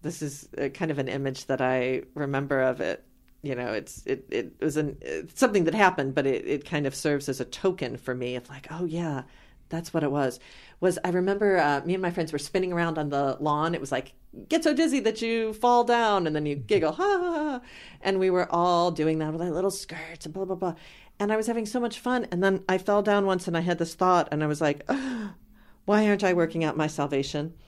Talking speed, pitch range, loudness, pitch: 255 wpm, 145-195 Hz, -27 LUFS, 165 Hz